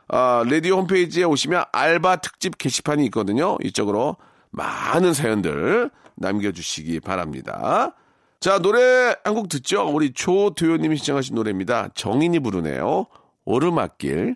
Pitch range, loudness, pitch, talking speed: 110-180 Hz, -21 LUFS, 150 Hz, 320 characters per minute